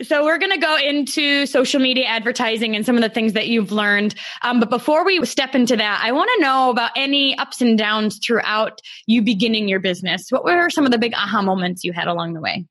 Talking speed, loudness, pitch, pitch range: 240 wpm, -17 LUFS, 235 Hz, 210-275 Hz